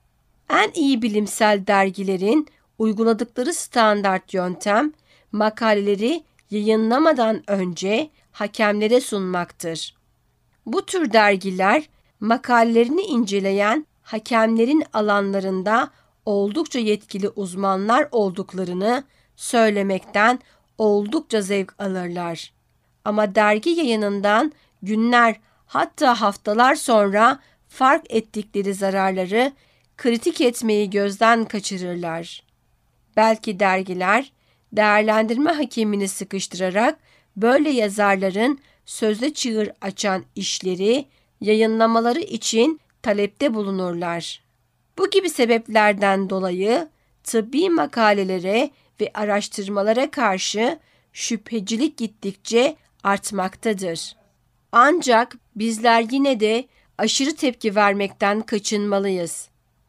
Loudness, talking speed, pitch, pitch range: -20 LUFS, 75 wpm, 215 Hz, 200-240 Hz